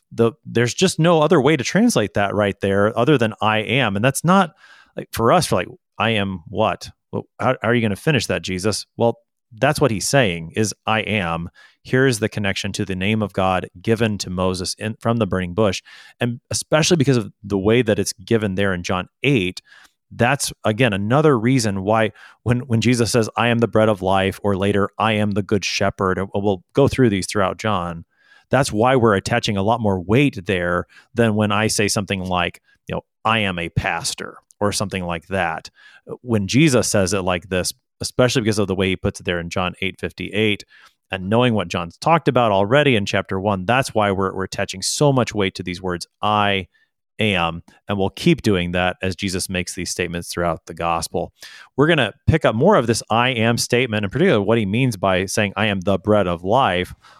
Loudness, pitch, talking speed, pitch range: -19 LUFS, 105 Hz, 215 wpm, 95-115 Hz